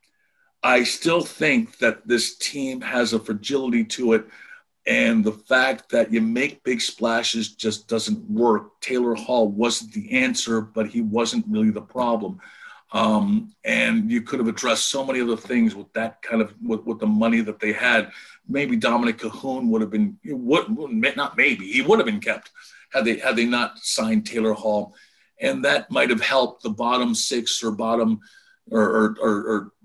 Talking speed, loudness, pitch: 180 wpm, -22 LUFS, 120 Hz